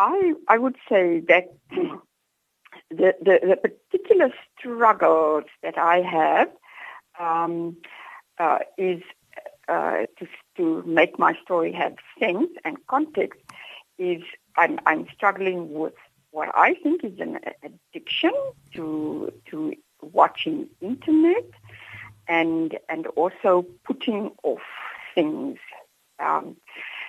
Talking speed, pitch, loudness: 105 wpm, 230 Hz, -23 LUFS